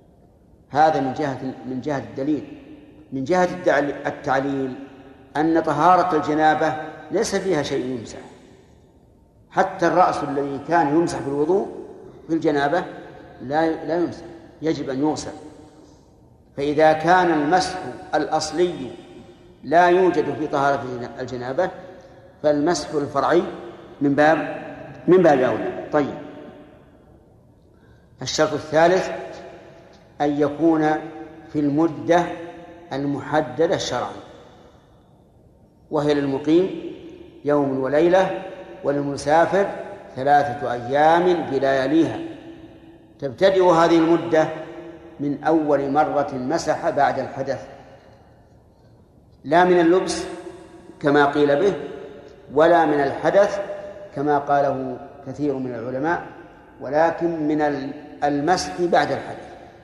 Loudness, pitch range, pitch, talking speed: -21 LUFS, 145-175 Hz, 155 Hz, 90 wpm